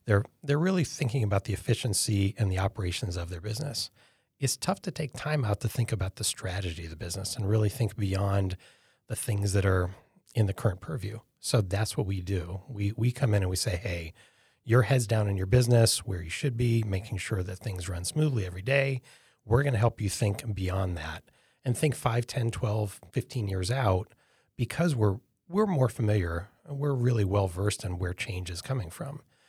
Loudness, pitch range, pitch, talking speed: -29 LUFS, 95-125 Hz, 110 Hz, 210 wpm